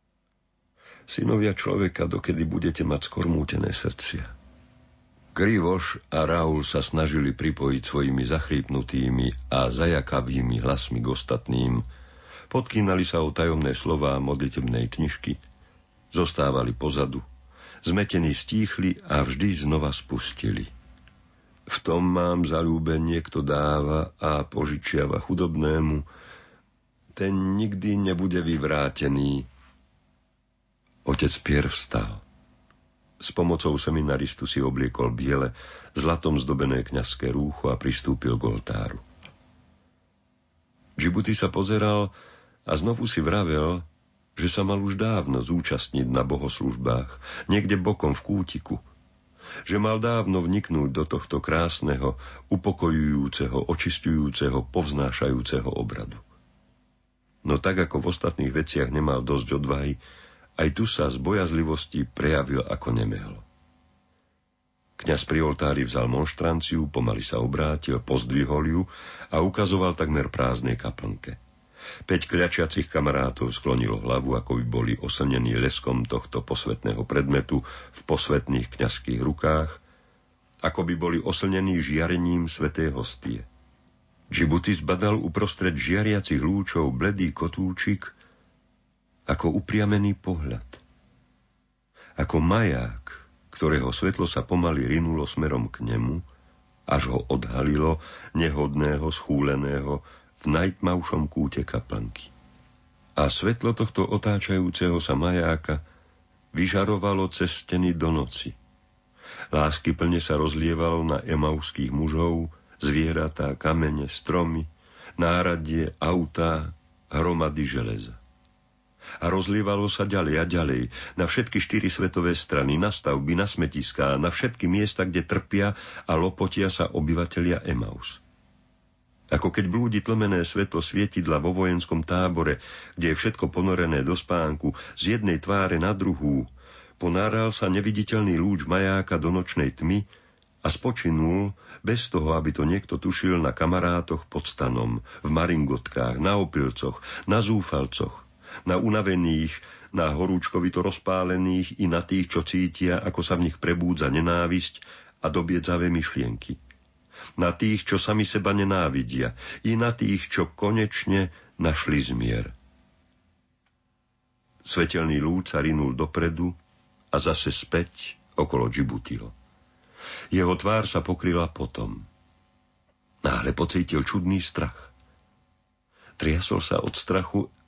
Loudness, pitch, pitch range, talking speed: -26 LUFS, 80 Hz, 70-90 Hz, 110 wpm